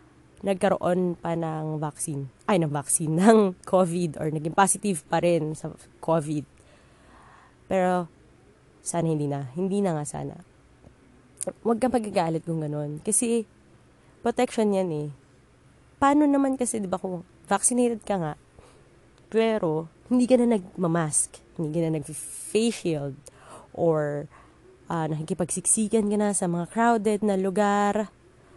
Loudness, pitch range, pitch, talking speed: -25 LUFS, 155-210 Hz, 180 Hz, 130 wpm